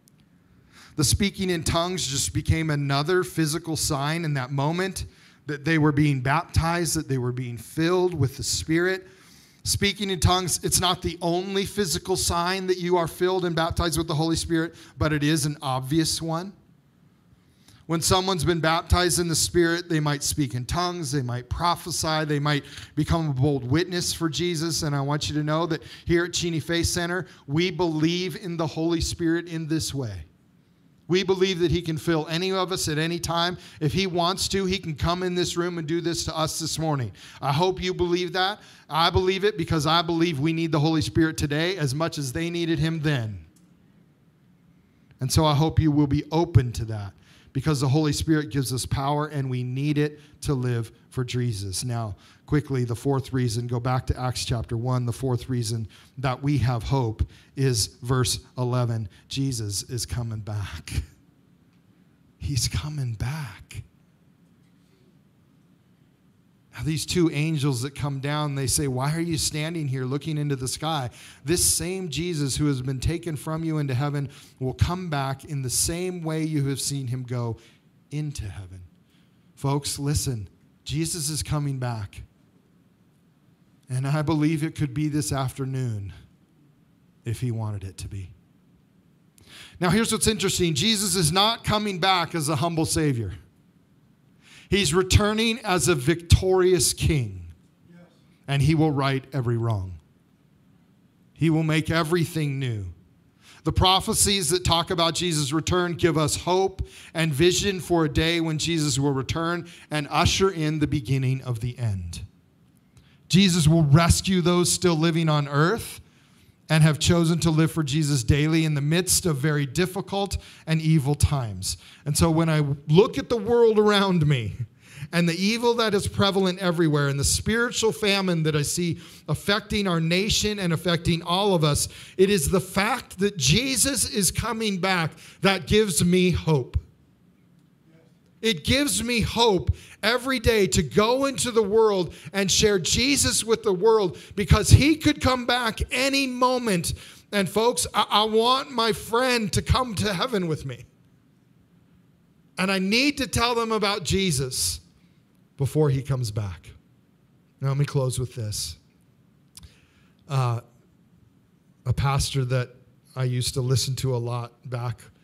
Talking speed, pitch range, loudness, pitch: 165 wpm, 135-175 Hz, -24 LUFS, 155 Hz